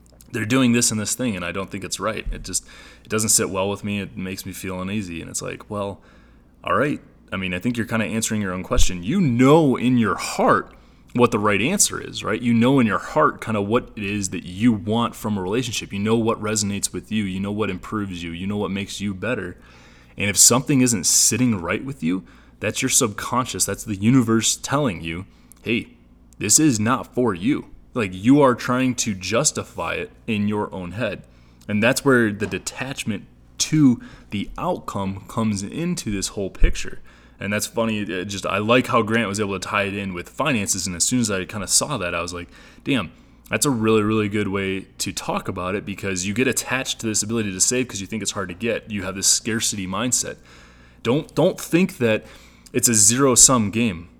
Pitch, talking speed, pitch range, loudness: 105 Hz, 225 wpm, 95-115 Hz, -21 LUFS